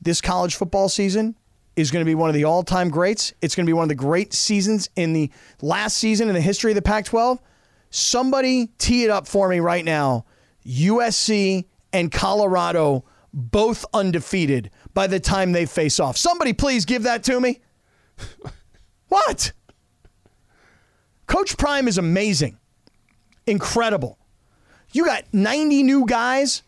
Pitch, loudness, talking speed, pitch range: 195 Hz, -20 LUFS, 155 wpm, 165-230 Hz